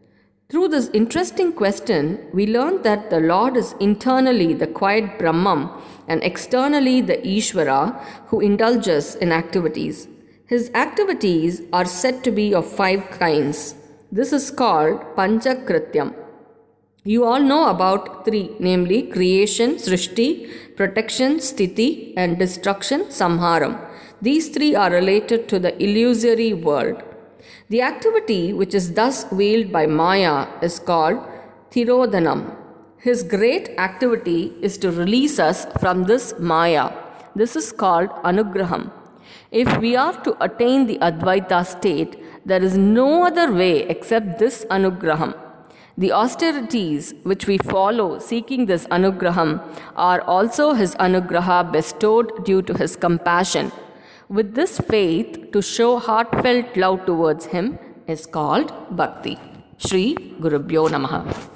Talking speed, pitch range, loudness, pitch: 125 wpm, 180-240 Hz, -19 LUFS, 205 Hz